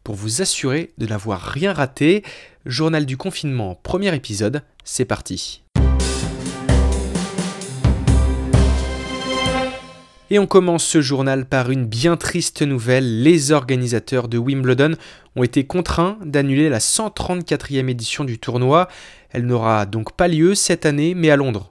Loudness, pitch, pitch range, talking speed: -19 LUFS, 135 Hz, 115-165 Hz, 130 wpm